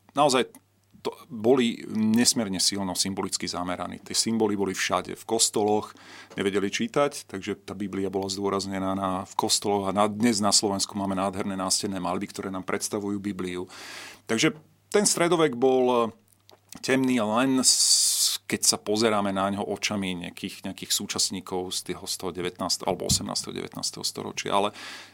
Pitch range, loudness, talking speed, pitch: 95-115 Hz, -25 LUFS, 145 wpm, 100 Hz